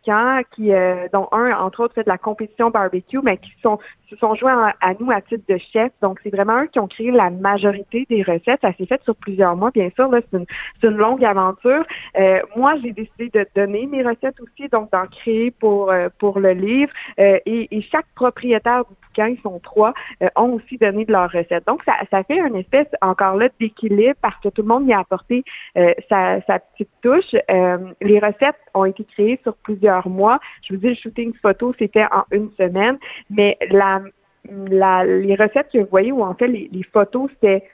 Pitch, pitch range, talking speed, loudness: 215 Hz, 195-240 Hz, 220 wpm, -18 LUFS